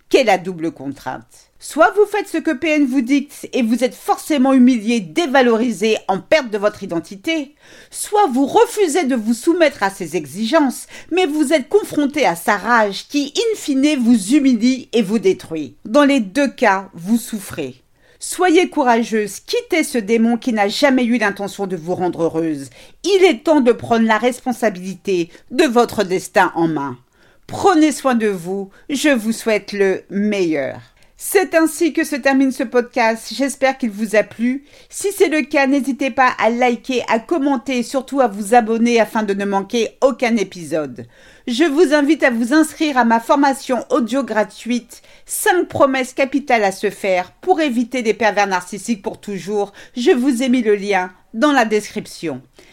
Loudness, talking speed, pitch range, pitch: -17 LUFS, 175 wpm, 205-290 Hz, 245 Hz